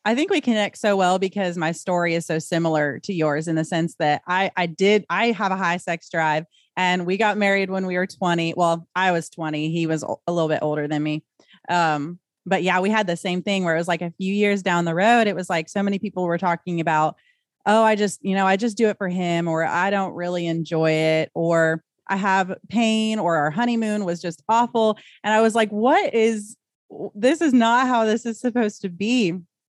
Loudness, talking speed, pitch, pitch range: -21 LUFS, 235 wpm, 185 Hz, 165-210 Hz